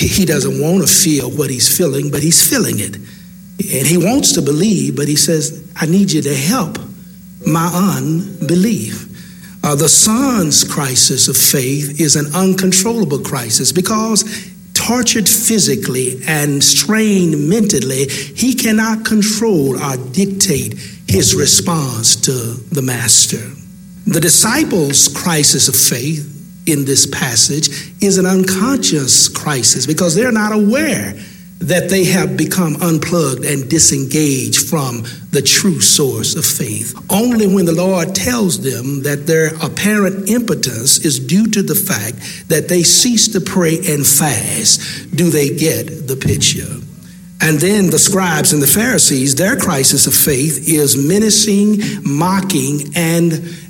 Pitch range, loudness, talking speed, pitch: 145-190 Hz, -12 LUFS, 140 wpm, 165 Hz